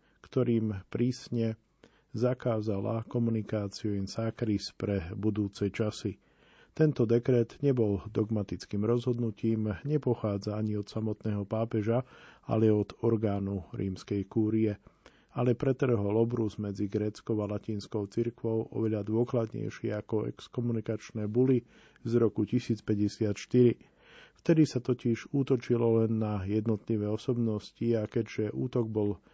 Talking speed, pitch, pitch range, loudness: 105 wpm, 110 Hz, 105-120 Hz, -31 LUFS